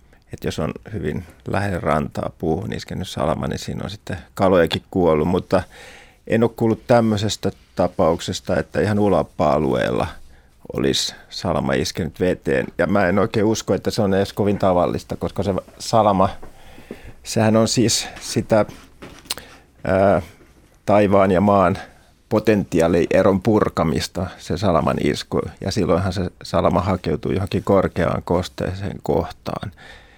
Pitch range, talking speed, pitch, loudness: 80-105 Hz, 125 wpm, 95 Hz, -20 LUFS